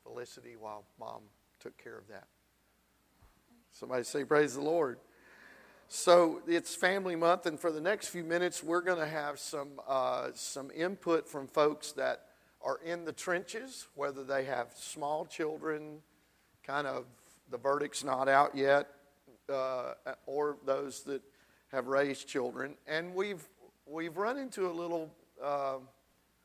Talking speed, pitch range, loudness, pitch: 145 wpm, 135-170 Hz, -34 LUFS, 145 Hz